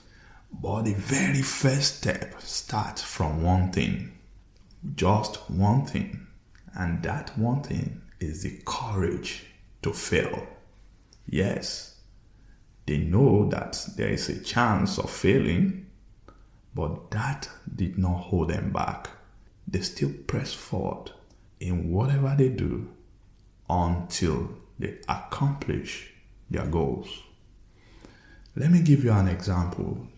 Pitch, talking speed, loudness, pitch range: 100 Hz, 115 wpm, -27 LUFS, 90-115 Hz